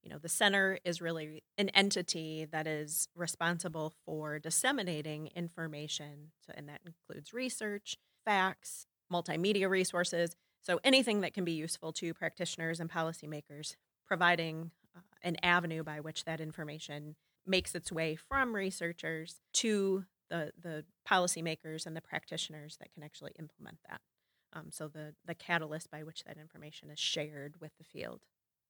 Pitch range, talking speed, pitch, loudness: 155-180 Hz, 150 wpm, 165 Hz, -35 LUFS